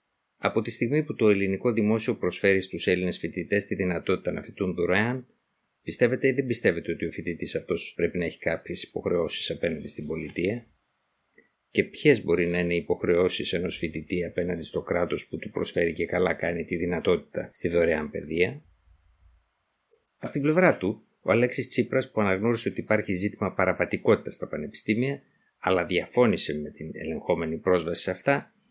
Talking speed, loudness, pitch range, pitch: 165 wpm, -27 LUFS, 85-120 Hz, 95 Hz